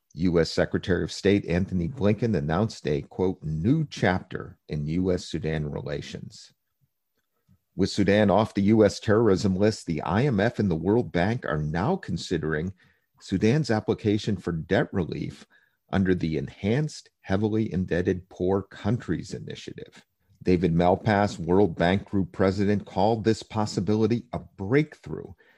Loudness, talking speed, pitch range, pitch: -25 LUFS, 125 wpm, 90-110 Hz, 95 Hz